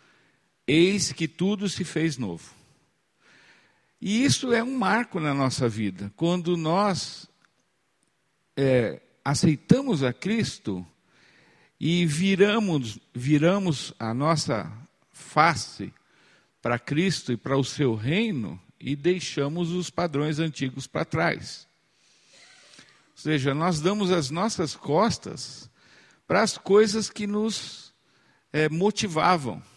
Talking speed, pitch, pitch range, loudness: 110 wpm, 165 Hz, 140-195 Hz, -25 LUFS